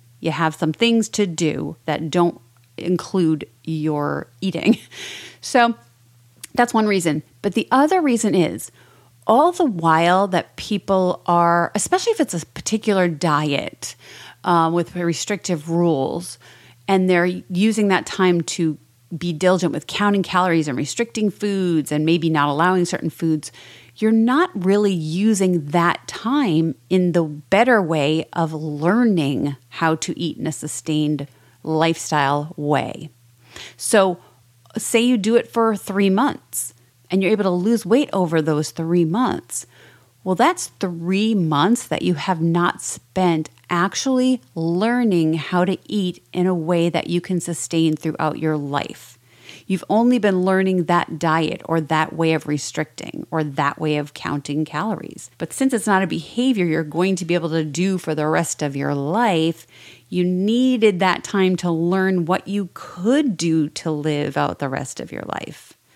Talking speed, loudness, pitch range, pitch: 155 wpm, -20 LUFS, 155-195 Hz, 170 Hz